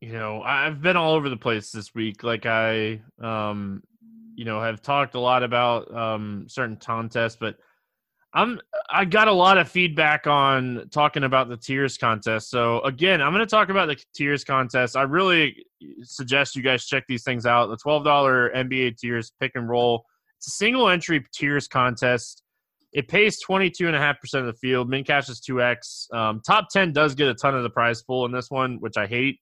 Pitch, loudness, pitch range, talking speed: 130 Hz, -22 LUFS, 120-150 Hz, 210 wpm